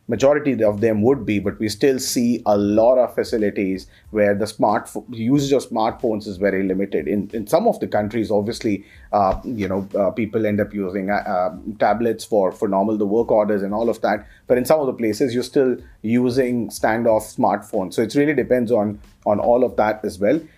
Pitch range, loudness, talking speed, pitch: 105-120 Hz, -20 LUFS, 210 wpm, 110 Hz